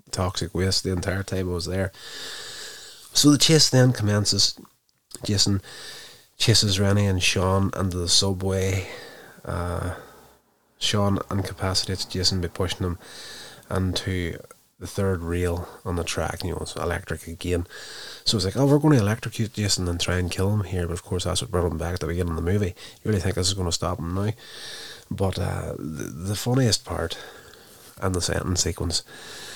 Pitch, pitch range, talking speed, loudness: 95 Hz, 90-105 Hz, 180 wpm, -24 LUFS